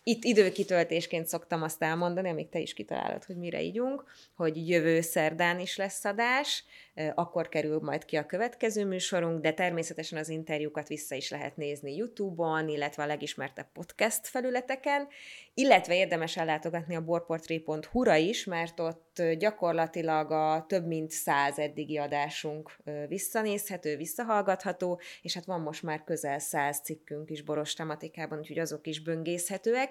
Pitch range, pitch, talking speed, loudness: 155-185 Hz, 165 Hz, 140 wpm, -31 LUFS